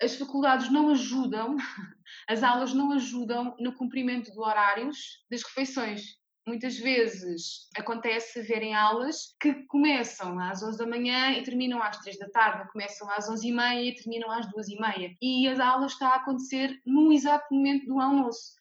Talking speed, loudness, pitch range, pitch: 170 wpm, -28 LUFS, 220-265 Hz, 245 Hz